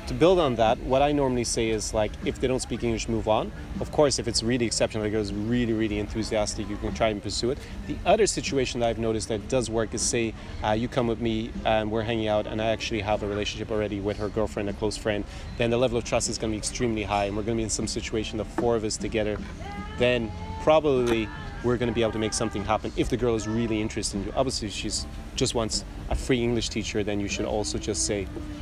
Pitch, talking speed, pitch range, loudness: 110 Hz, 255 wpm, 105-115 Hz, -26 LUFS